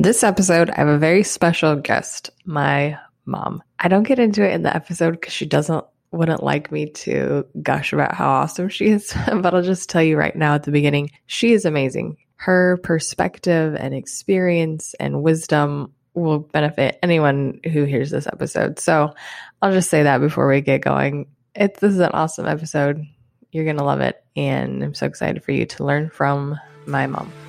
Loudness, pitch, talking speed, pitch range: -19 LUFS, 155 Hz, 190 wpm, 145-180 Hz